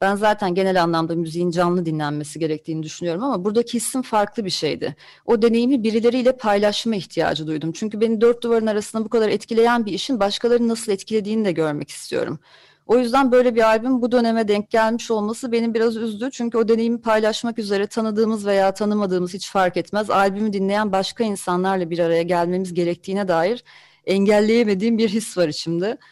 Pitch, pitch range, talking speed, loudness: 215 Hz, 185-230 Hz, 170 wpm, -20 LUFS